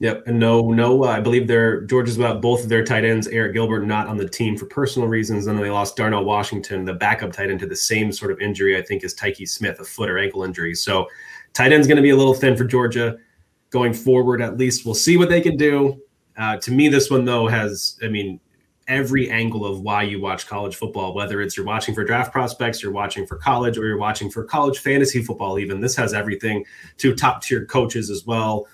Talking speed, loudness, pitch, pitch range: 245 wpm, -19 LUFS, 115 Hz, 105-125 Hz